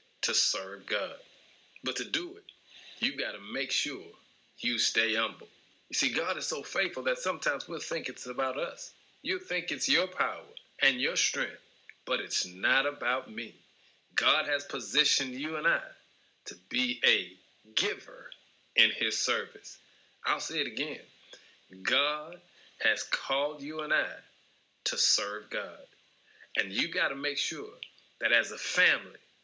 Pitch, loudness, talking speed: 365 Hz, -30 LUFS, 155 wpm